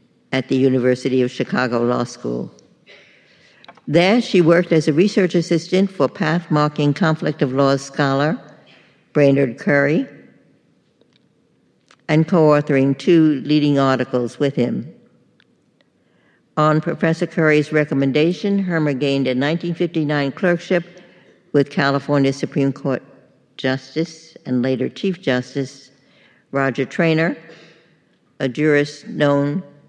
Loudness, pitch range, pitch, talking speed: -18 LUFS, 135-165 Hz, 150 Hz, 105 wpm